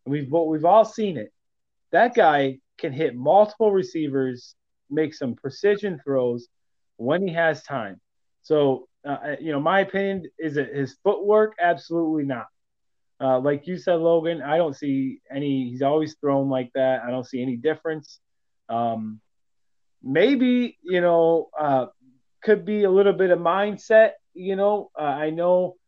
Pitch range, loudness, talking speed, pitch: 130-180 Hz, -22 LUFS, 160 wpm, 155 Hz